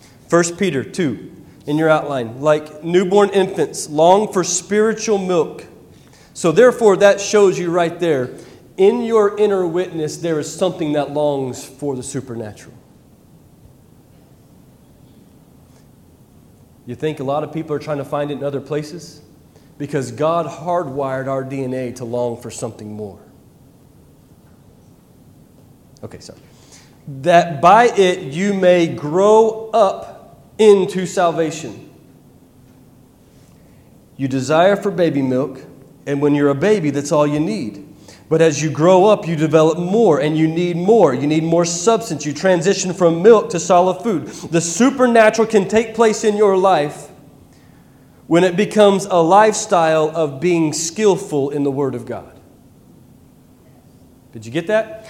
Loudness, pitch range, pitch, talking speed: -16 LUFS, 140-195 Hz, 165 Hz, 140 wpm